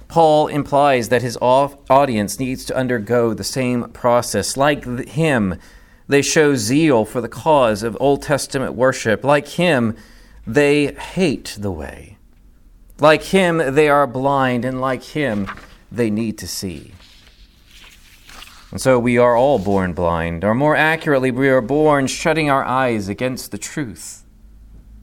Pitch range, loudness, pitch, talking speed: 105-140 Hz, -17 LUFS, 125 Hz, 145 wpm